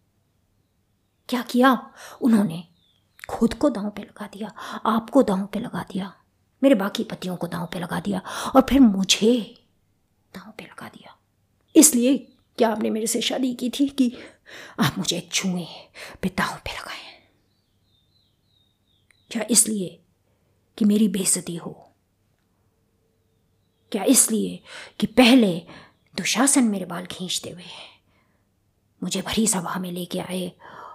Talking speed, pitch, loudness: 125 wpm, 190 Hz, -22 LUFS